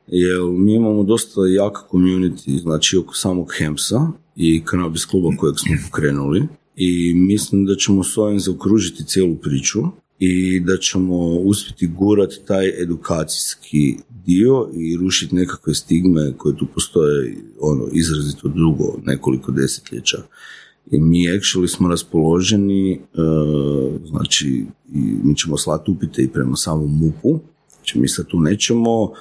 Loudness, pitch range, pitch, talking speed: -17 LUFS, 80-100 Hz, 90 Hz, 135 wpm